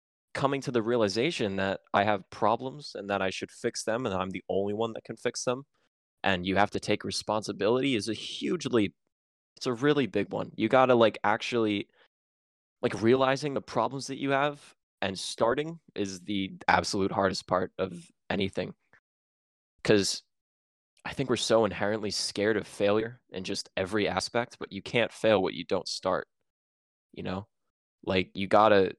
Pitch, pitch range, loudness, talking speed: 100 Hz, 95-115 Hz, -29 LUFS, 170 wpm